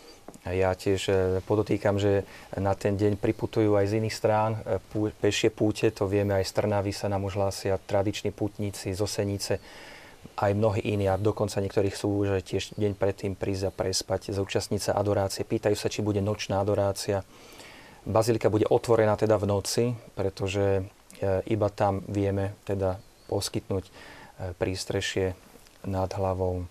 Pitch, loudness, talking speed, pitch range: 100 Hz, -28 LUFS, 140 wpm, 95-105 Hz